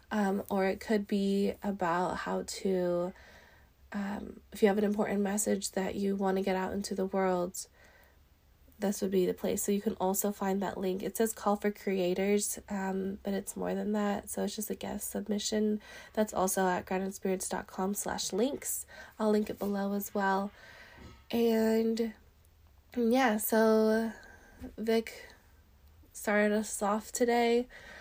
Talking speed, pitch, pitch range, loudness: 155 wpm, 200 Hz, 190-215 Hz, -32 LUFS